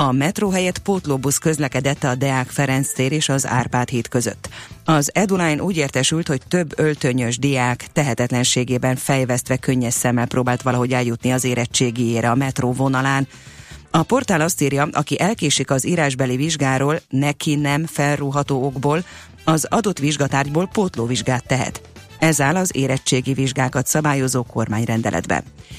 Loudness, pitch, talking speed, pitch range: -19 LUFS, 135 Hz, 135 wpm, 125-150 Hz